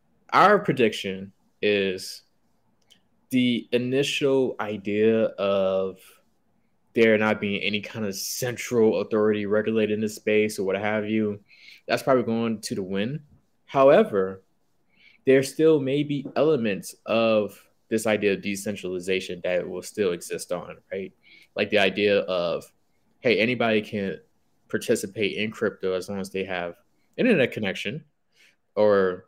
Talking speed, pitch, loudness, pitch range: 135 wpm, 105 Hz, -24 LUFS, 95-115 Hz